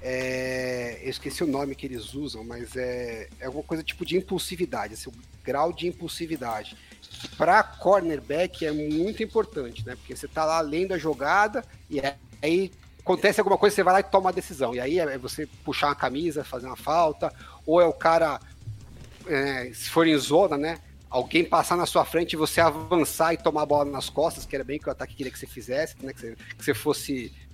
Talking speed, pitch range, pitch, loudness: 210 wpm, 130-170 Hz, 150 Hz, -26 LUFS